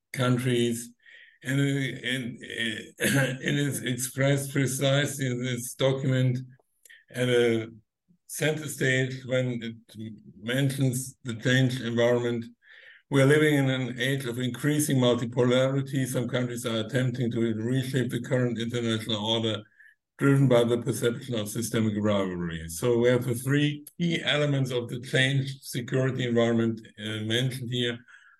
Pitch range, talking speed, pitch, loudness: 120-135 Hz, 130 wpm, 125 Hz, -27 LUFS